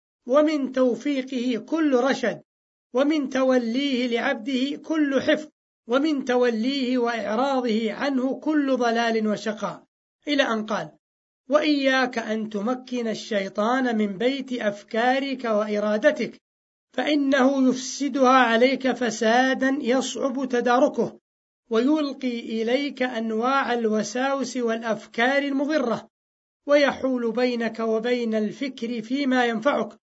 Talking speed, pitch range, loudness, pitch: 90 wpm, 230-270 Hz, -23 LUFS, 250 Hz